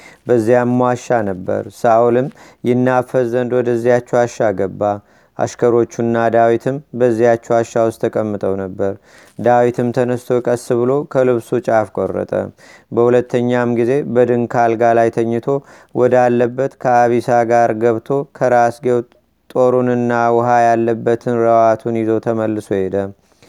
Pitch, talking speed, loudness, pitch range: 120 Hz, 100 wpm, -15 LUFS, 115-125 Hz